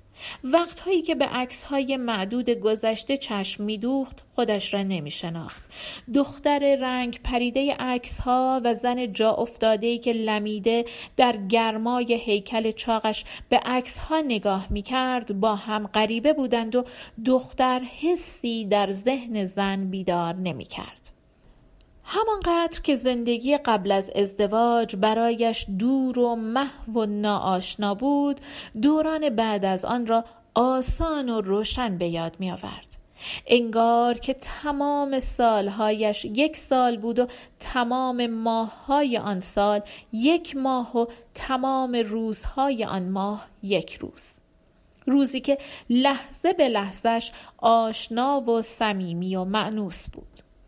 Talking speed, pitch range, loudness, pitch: 120 wpm, 215-260 Hz, -24 LUFS, 235 Hz